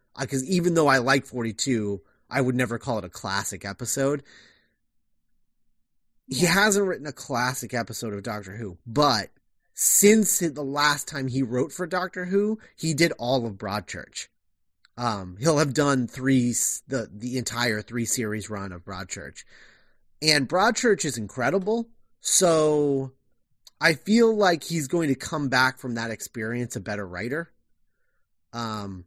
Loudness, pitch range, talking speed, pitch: -24 LUFS, 110-155 Hz, 150 wpm, 130 Hz